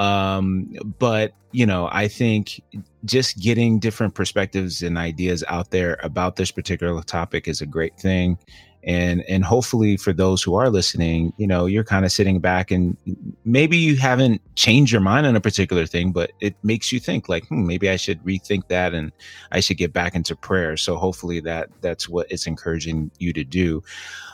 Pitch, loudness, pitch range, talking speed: 95 Hz, -21 LUFS, 85-105 Hz, 190 wpm